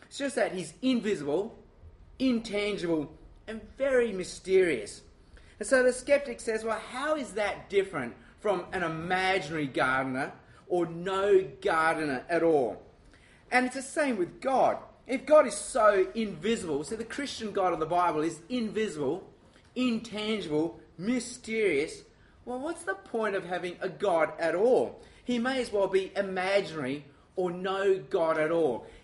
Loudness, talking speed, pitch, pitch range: -29 LUFS, 145 wpm, 205 Hz, 175-250 Hz